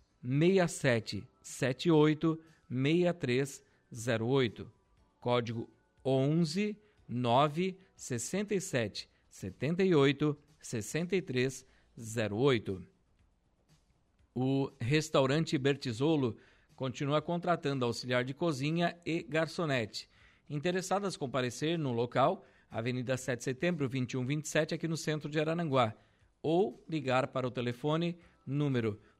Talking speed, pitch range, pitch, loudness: 110 wpm, 120-160 Hz, 135 Hz, -33 LUFS